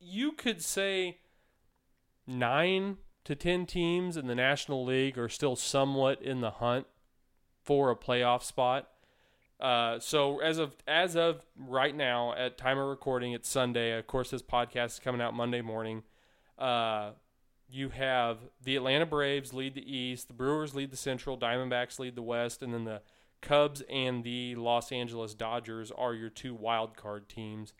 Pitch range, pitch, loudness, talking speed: 120-140 Hz, 130 Hz, -32 LUFS, 165 wpm